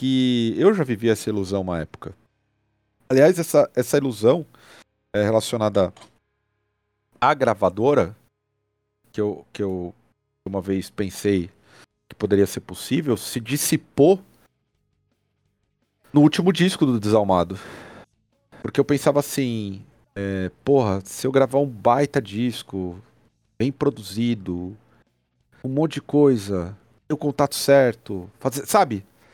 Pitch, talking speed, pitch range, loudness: 110 Hz, 120 wpm, 100-135 Hz, -21 LUFS